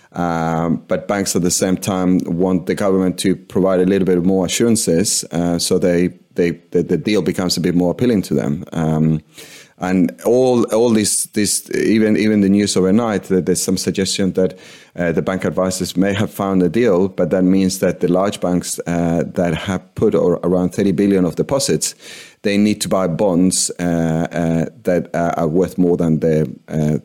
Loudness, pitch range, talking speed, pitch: -17 LUFS, 85-95 Hz, 195 wpm, 90 Hz